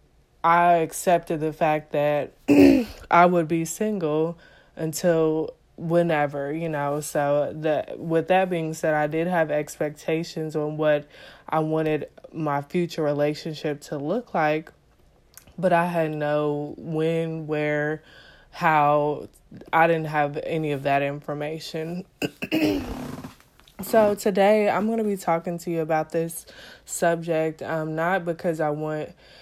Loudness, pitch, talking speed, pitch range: -24 LUFS, 160 Hz, 130 wpm, 150-170 Hz